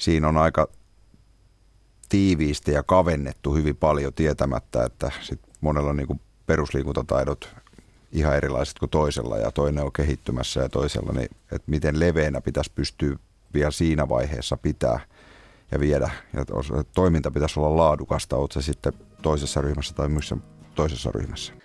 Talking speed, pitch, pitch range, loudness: 145 wpm, 75 Hz, 70-80 Hz, -25 LUFS